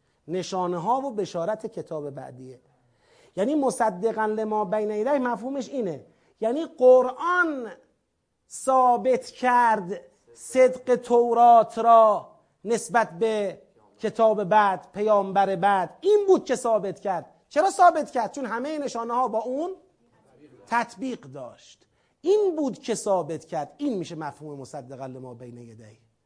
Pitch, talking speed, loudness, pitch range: 225 Hz, 120 wpm, -23 LUFS, 190-255 Hz